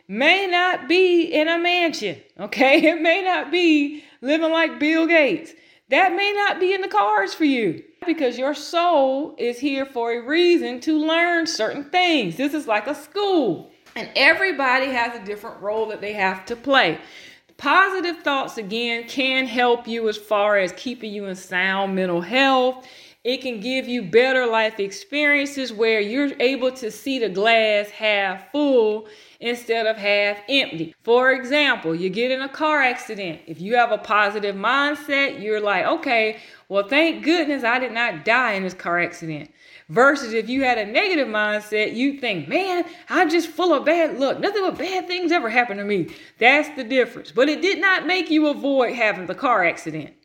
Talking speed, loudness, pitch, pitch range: 185 wpm, -20 LUFS, 260 Hz, 220-320 Hz